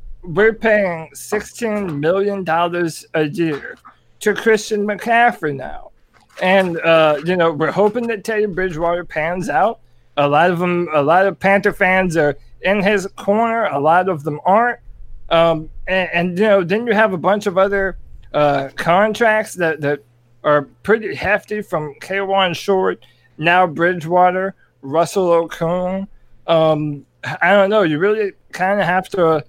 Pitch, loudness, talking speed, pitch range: 180 Hz, -17 LUFS, 155 wpm, 160-205 Hz